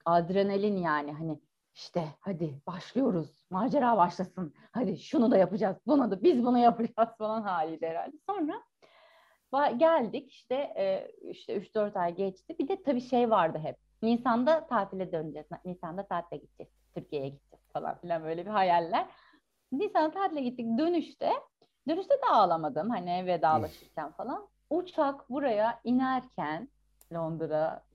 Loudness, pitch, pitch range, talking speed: -30 LUFS, 220 Hz, 175-285 Hz, 130 wpm